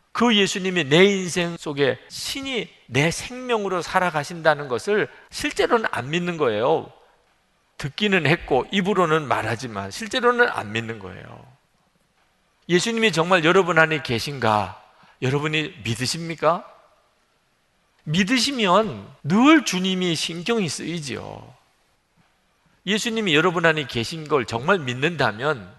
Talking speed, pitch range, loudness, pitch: 265 characters per minute, 140-200 Hz, -21 LUFS, 170 Hz